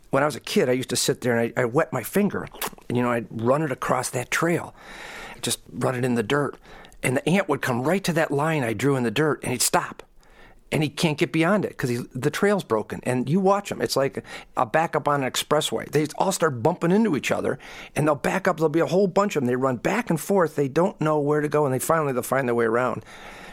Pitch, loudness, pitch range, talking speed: 145 Hz, -23 LUFS, 125-165 Hz, 270 wpm